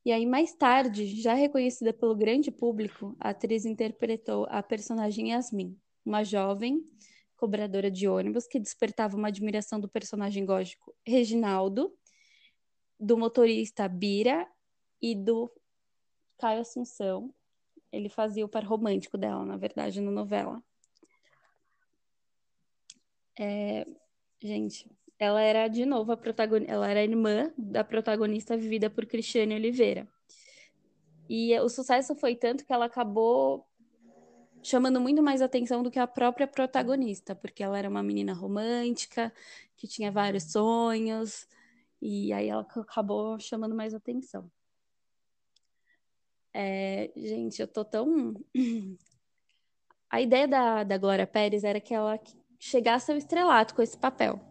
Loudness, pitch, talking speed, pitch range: -29 LUFS, 225 Hz, 130 wpm, 205-245 Hz